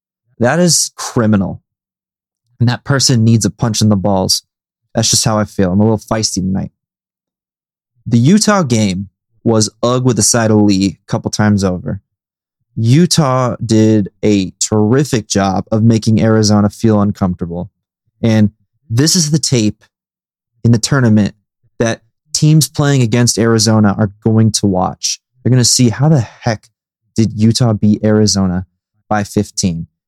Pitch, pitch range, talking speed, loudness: 110 Hz, 100-120 Hz, 150 wpm, -13 LUFS